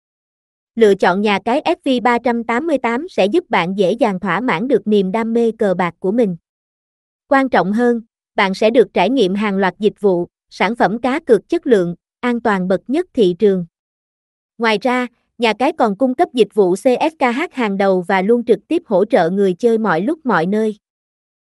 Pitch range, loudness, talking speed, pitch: 200-250 Hz, -16 LUFS, 190 wpm, 225 Hz